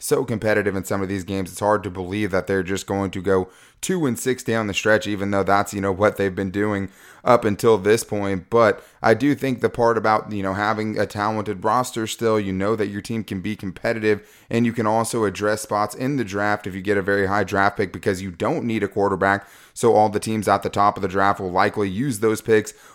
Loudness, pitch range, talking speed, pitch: -21 LUFS, 100-110 Hz, 250 wpm, 105 Hz